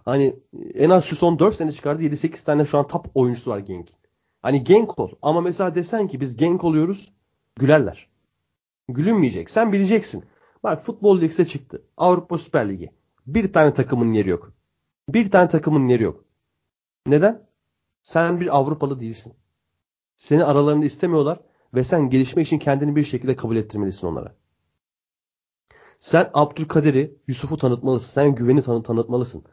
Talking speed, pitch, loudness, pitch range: 150 wpm, 145 Hz, -20 LUFS, 120-170 Hz